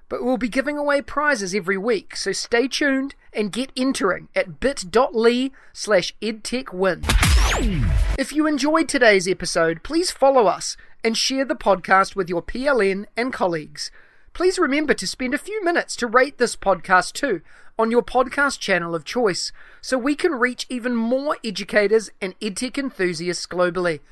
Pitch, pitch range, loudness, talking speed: 240 Hz, 195-275 Hz, -21 LUFS, 155 wpm